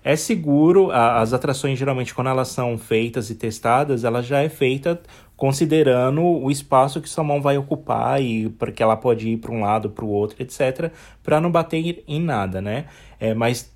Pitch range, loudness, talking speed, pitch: 115-150 Hz, -20 LUFS, 190 wpm, 130 Hz